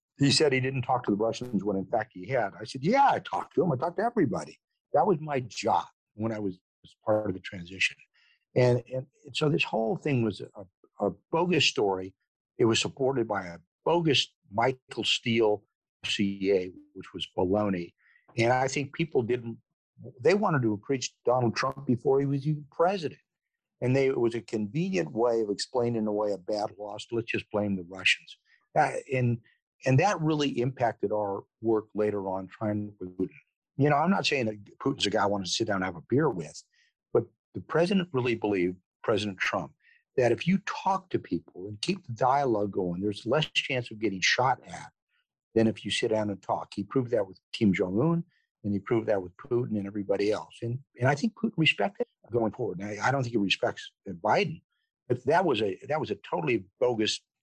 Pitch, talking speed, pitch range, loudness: 115 Hz, 205 wpm, 105-140 Hz, -28 LUFS